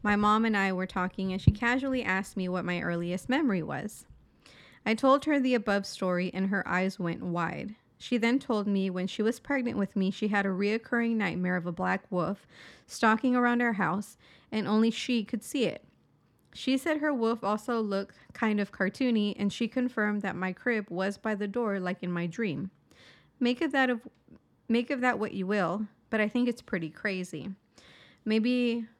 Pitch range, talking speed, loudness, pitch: 190-235 Hz, 200 wpm, -29 LUFS, 210 Hz